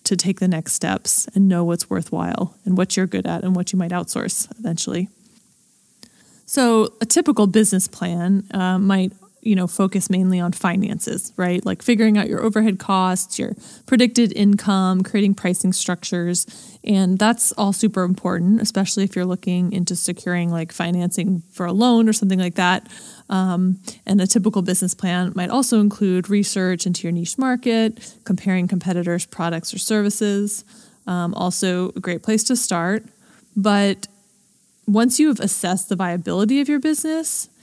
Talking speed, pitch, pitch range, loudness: 165 wpm, 195 Hz, 180-220 Hz, -19 LUFS